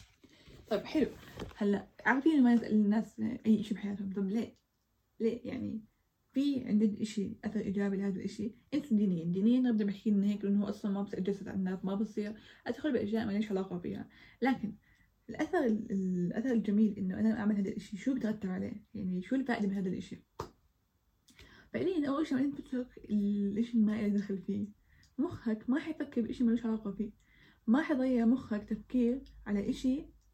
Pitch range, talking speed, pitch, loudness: 205-245 Hz, 165 wpm, 215 Hz, -33 LUFS